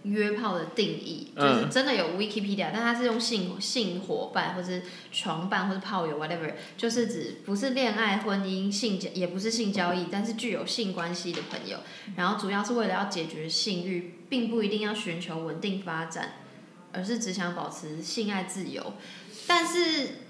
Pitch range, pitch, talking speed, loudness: 175-225 Hz, 195 Hz, 310 characters per minute, -29 LUFS